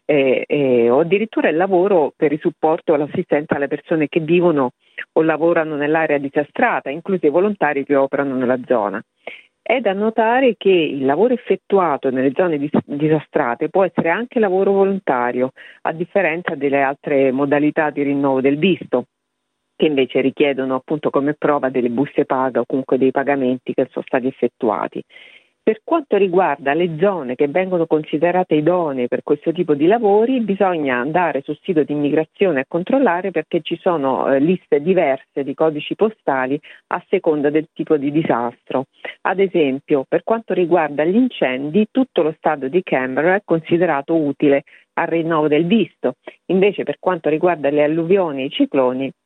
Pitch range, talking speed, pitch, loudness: 140-180 Hz, 160 wpm, 155 Hz, -18 LUFS